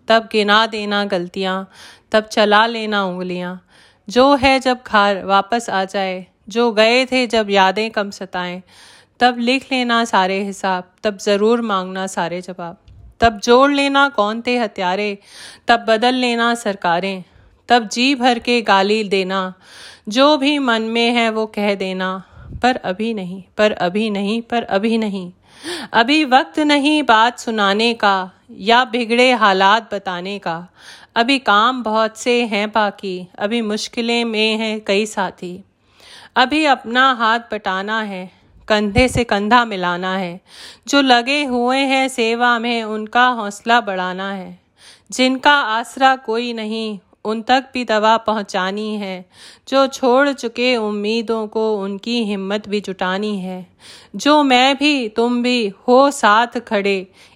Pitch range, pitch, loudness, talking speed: 195-245 Hz, 220 Hz, -16 LUFS, 145 wpm